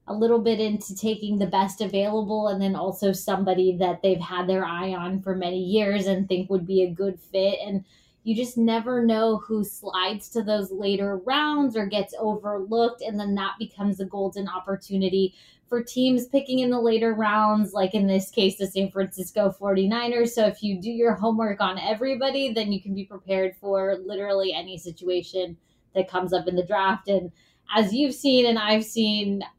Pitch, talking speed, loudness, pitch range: 200 Hz, 190 wpm, -25 LUFS, 190-220 Hz